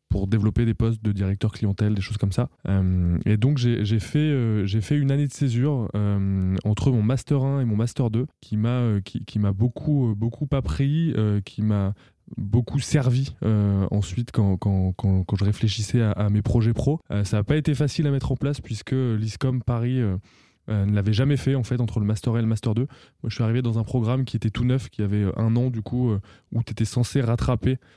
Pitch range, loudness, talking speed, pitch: 105-130 Hz, -24 LUFS, 235 wpm, 115 Hz